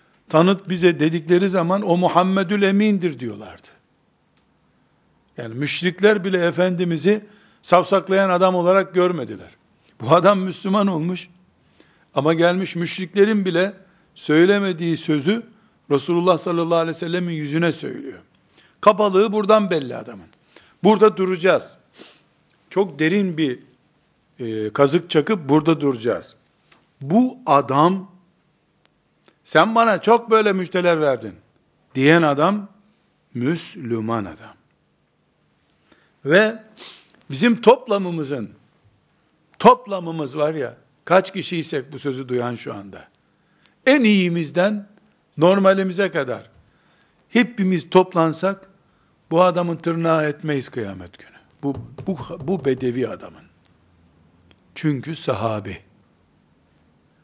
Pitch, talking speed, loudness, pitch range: 175 Hz, 95 wpm, -19 LUFS, 145-195 Hz